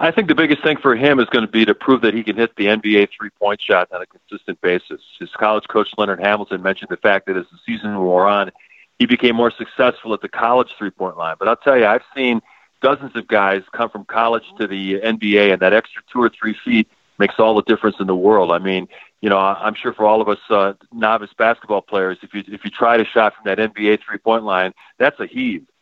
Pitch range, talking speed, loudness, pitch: 100-115 Hz, 245 wpm, -17 LUFS, 110 Hz